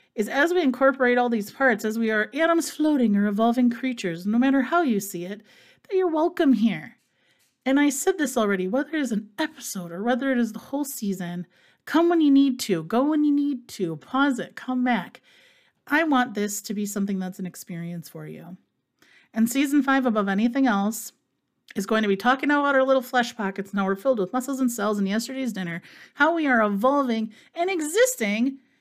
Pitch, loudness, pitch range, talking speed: 245 Hz, -23 LUFS, 205-280 Hz, 205 wpm